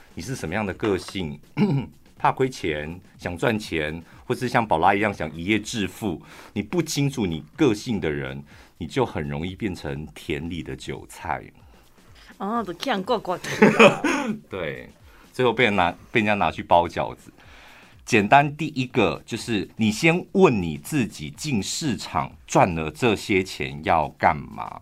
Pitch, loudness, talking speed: 105 Hz, -23 LUFS, 215 characters per minute